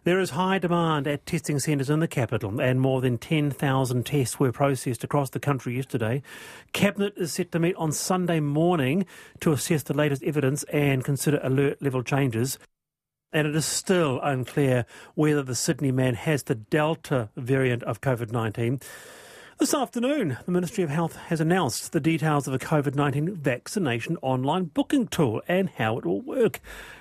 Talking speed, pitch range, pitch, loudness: 175 wpm, 130-165 Hz, 145 Hz, -25 LUFS